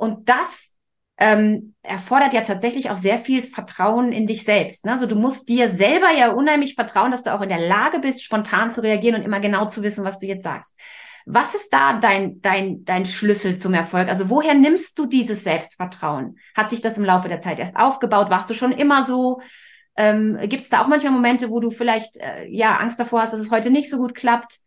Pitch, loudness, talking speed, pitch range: 225 Hz, -19 LUFS, 225 wpm, 205-255 Hz